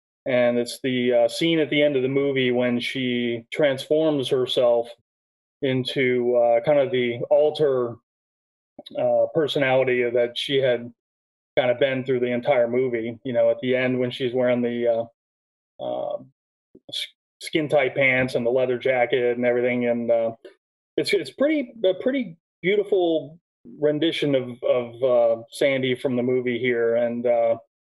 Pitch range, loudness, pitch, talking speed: 120-145 Hz, -22 LUFS, 125 Hz, 155 wpm